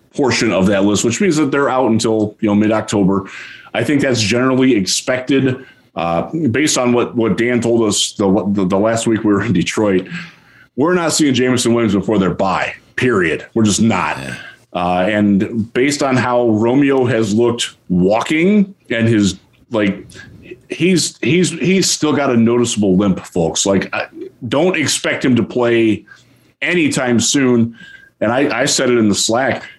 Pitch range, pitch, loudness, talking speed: 100-130 Hz, 115 Hz, -15 LUFS, 175 wpm